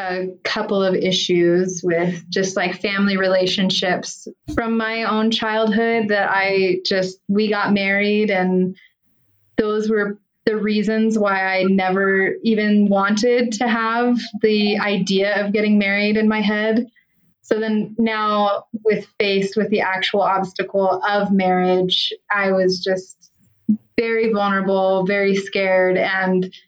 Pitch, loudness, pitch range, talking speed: 200 Hz, -18 LUFS, 190-215 Hz, 130 wpm